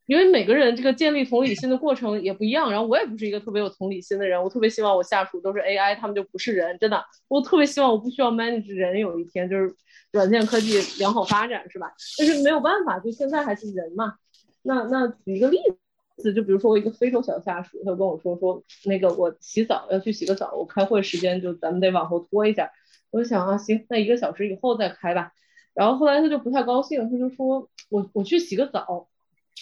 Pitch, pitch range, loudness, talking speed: 215 Hz, 190-255 Hz, -23 LUFS, 365 characters per minute